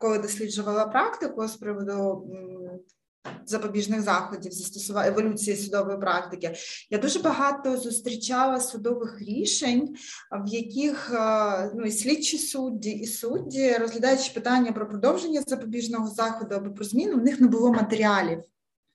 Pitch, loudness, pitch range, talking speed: 225 Hz, -26 LUFS, 205-255 Hz, 125 wpm